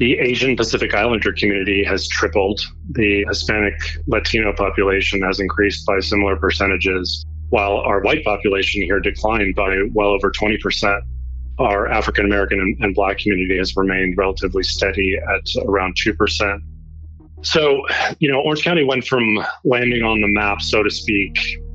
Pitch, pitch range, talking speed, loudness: 100 Hz, 90-105 Hz, 150 wpm, -17 LUFS